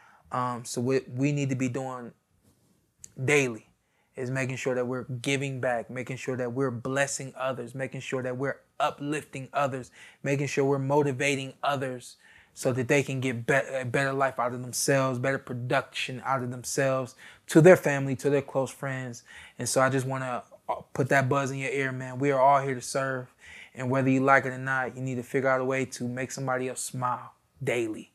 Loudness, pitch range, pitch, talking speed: -28 LUFS, 125-140 Hz, 130 Hz, 205 wpm